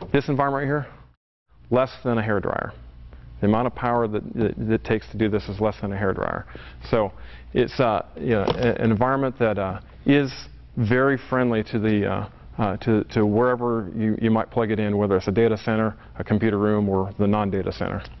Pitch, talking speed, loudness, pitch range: 110 Hz, 205 wpm, -23 LUFS, 100-120 Hz